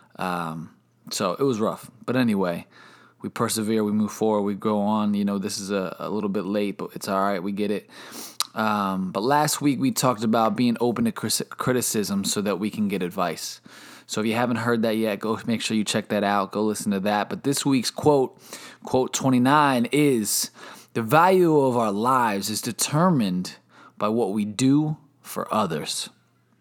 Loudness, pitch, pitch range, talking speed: -23 LUFS, 110 Hz, 105-140 Hz, 195 wpm